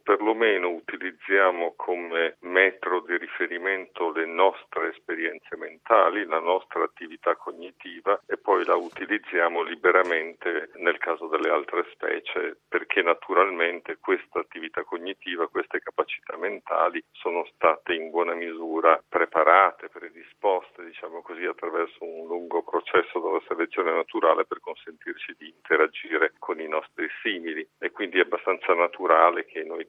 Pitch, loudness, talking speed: 380 Hz, -25 LUFS, 125 wpm